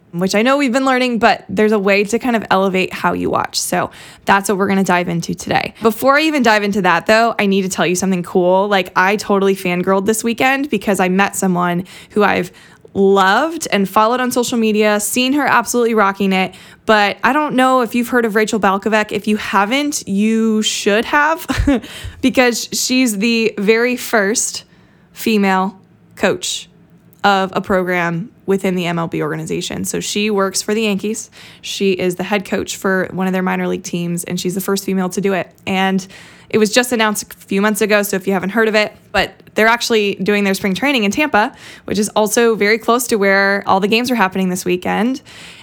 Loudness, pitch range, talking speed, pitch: -15 LUFS, 190-230 Hz, 210 wpm, 205 Hz